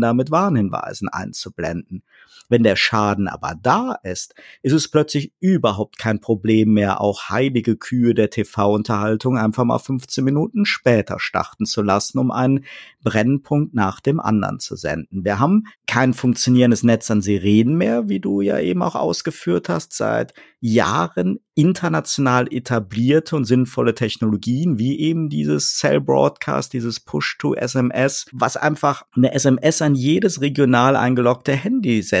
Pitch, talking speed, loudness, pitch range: 120 Hz, 145 wpm, -19 LUFS, 105-140 Hz